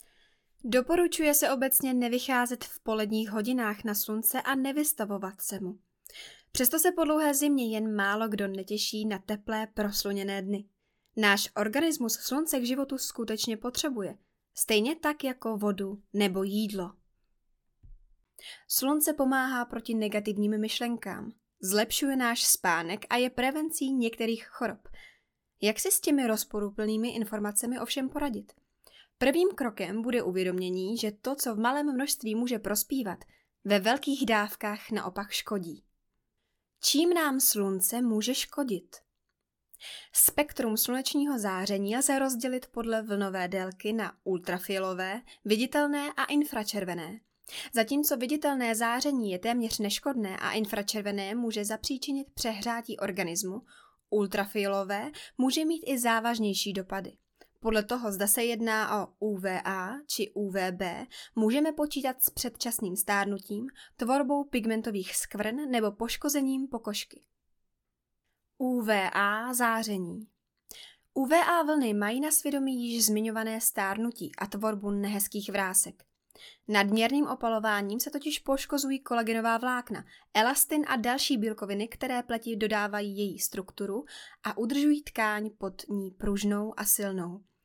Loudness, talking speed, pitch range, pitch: -29 LUFS, 115 wpm, 205-265 Hz, 225 Hz